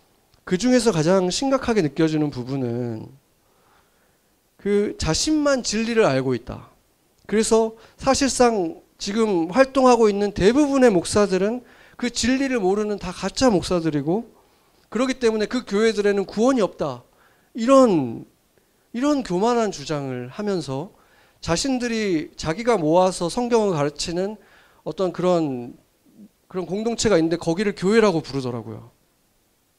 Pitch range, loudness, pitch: 170-240 Hz, -21 LUFS, 205 Hz